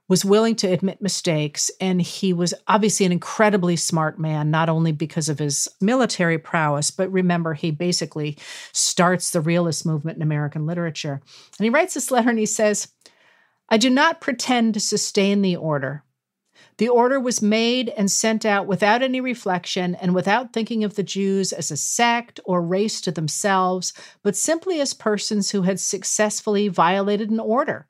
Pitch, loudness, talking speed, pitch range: 190 Hz, -21 LUFS, 170 wpm, 165-220 Hz